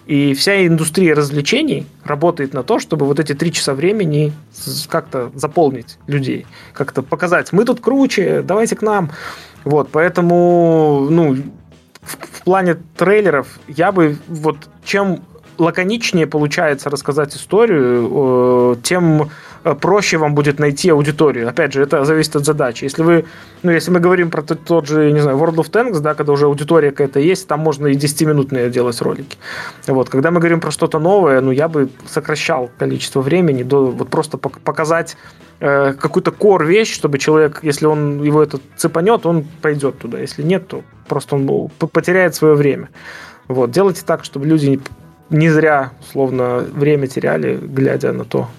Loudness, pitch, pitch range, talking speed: -15 LUFS, 155 Hz, 140-170 Hz, 160 wpm